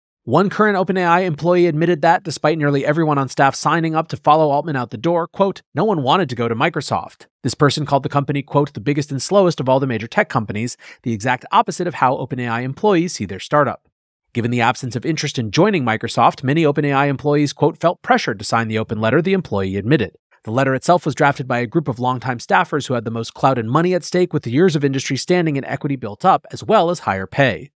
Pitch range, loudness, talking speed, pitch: 125-165 Hz, -18 LUFS, 240 wpm, 145 Hz